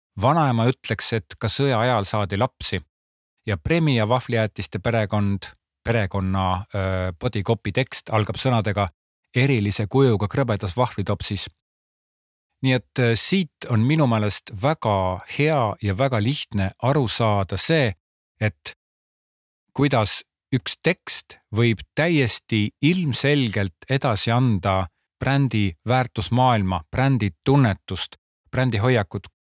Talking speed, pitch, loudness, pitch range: 110 wpm, 110 Hz, -22 LUFS, 100-130 Hz